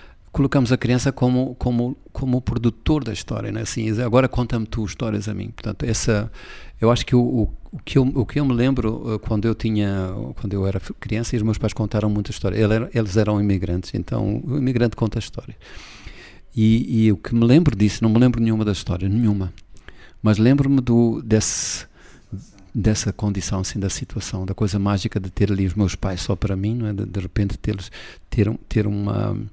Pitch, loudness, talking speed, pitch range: 110 Hz, -21 LUFS, 205 wpm, 100-120 Hz